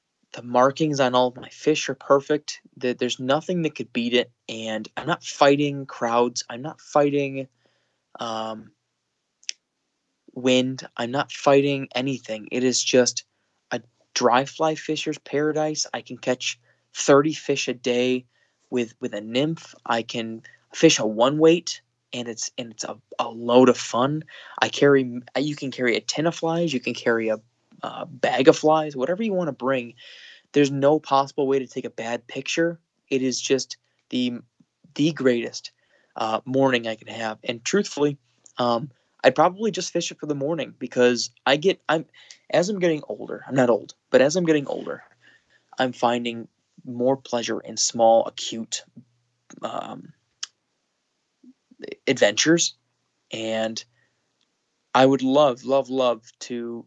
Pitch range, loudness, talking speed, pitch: 120-150 Hz, -23 LUFS, 155 wpm, 130 Hz